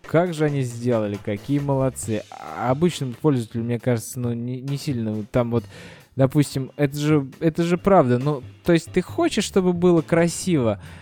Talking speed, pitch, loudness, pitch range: 175 wpm, 135 Hz, -22 LUFS, 120-165 Hz